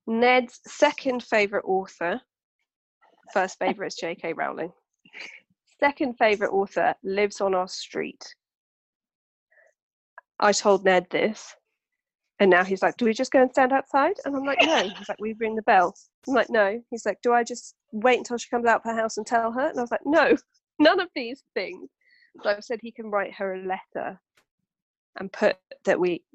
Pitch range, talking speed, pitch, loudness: 205-275 Hz, 185 wpm, 230 Hz, -24 LUFS